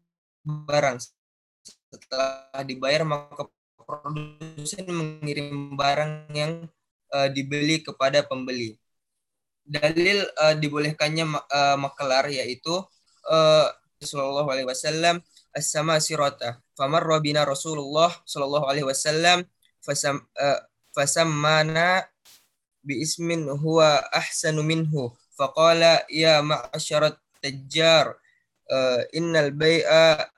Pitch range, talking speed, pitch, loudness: 140-160 Hz, 95 wpm, 150 Hz, -23 LUFS